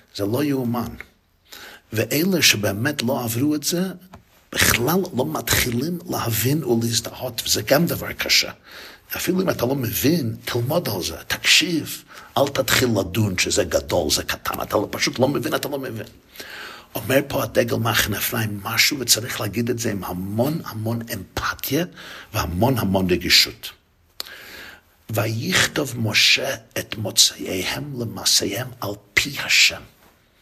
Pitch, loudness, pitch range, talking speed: 115 Hz, -20 LUFS, 105-135 Hz, 130 wpm